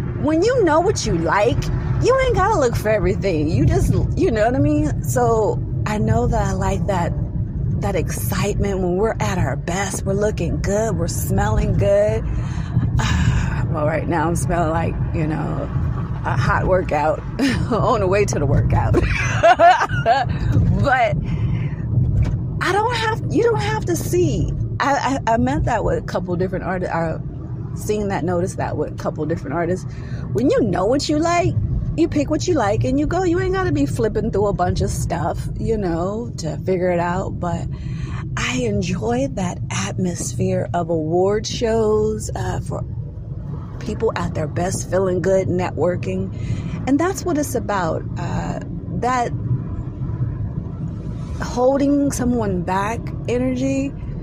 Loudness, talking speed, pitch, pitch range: -20 LUFS, 160 wpm, 165 Hz, 130-215 Hz